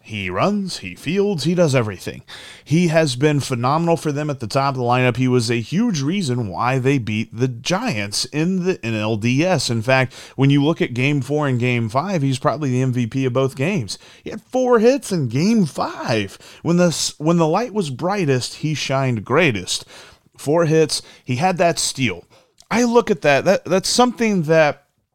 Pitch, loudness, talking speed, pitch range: 140 Hz, -19 LUFS, 195 wpm, 125-175 Hz